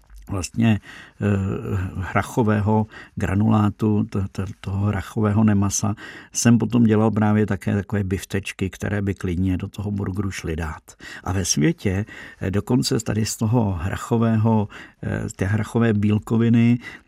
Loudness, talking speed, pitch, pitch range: -22 LUFS, 135 wpm, 105 Hz, 100-110 Hz